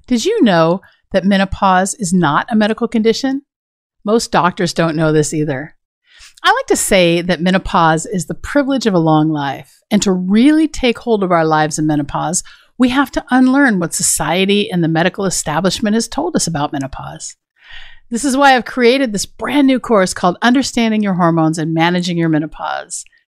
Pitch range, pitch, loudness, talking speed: 165-245 Hz, 195 Hz, -14 LUFS, 180 wpm